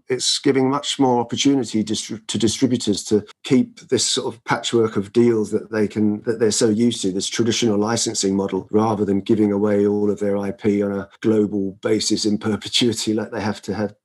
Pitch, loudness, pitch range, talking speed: 110 Hz, -20 LUFS, 105-115 Hz, 200 wpm